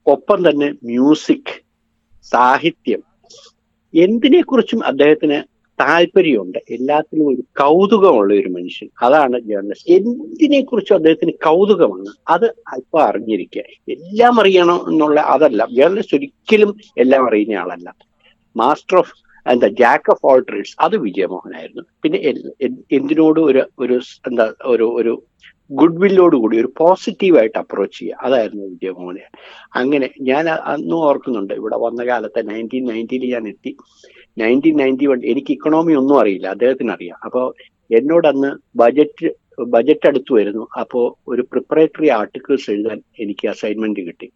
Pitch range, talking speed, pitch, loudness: 120-190 Hz, 120 wpm, 145 Hz, -15 LUFS